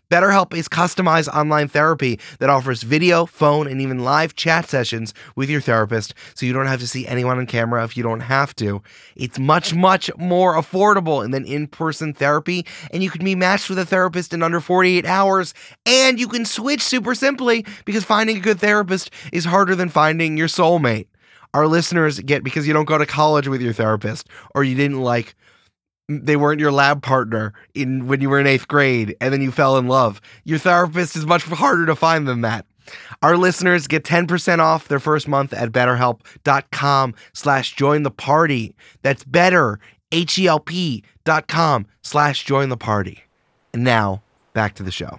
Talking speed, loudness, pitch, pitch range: 185 wpm, -18 LUFS, 150 Hz, 125-175 Hz